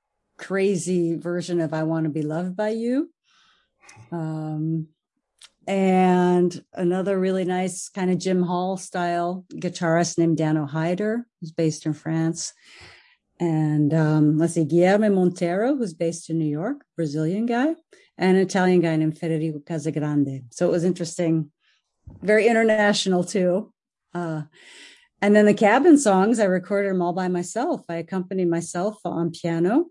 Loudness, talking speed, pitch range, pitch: -22 LUFS, 145 wpm, 165-200 Hz, 180 Hz